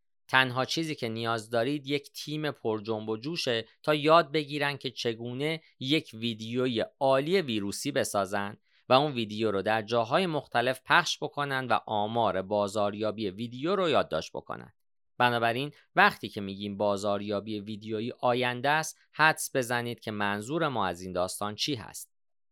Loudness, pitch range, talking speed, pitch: -29 LUFS, 105-145 Hz, 145 wpm, 120 Hz